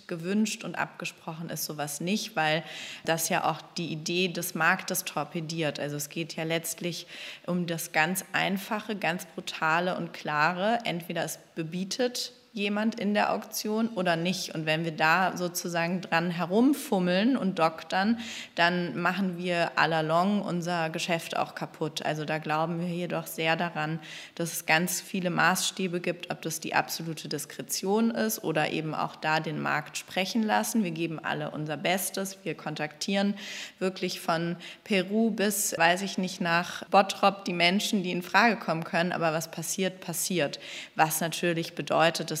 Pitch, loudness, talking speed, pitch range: 175 Hz, -28 LUFS, 160 wpm, 165-195 Hz